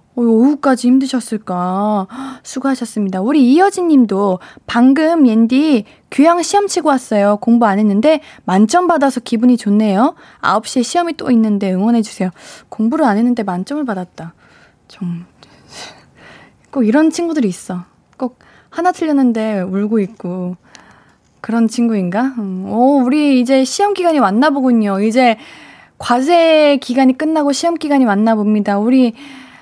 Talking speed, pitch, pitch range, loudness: 295 characters per minute, 245 Hz, 210-285 Hz, -14 LUFS